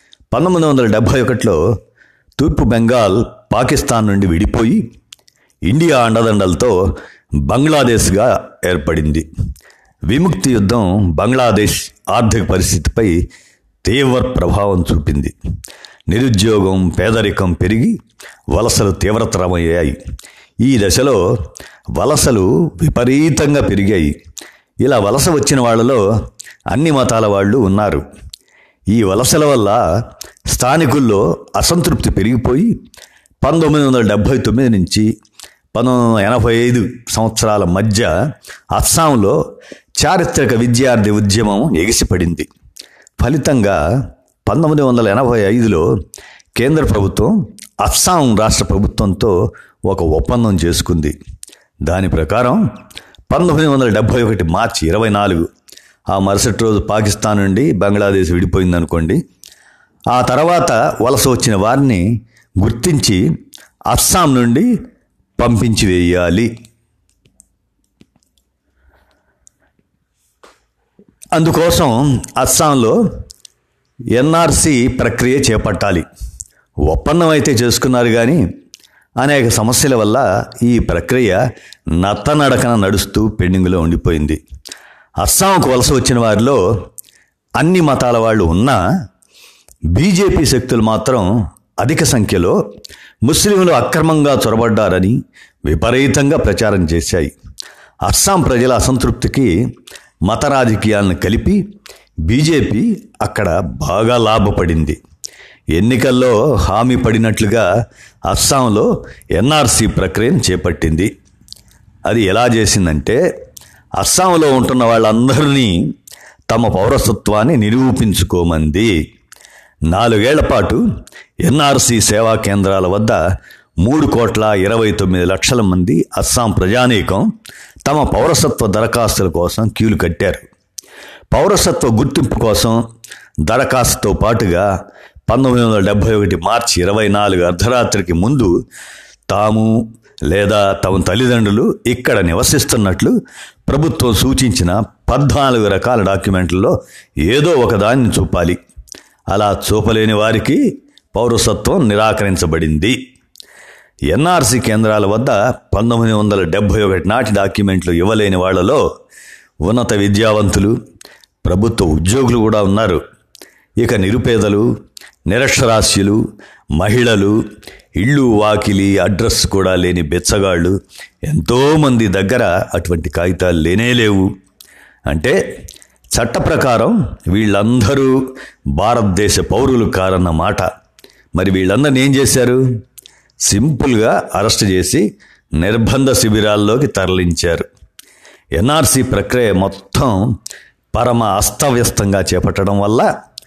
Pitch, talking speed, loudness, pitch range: 110 Hz, 85 wpm, -13 LUFS, 95-125 Hz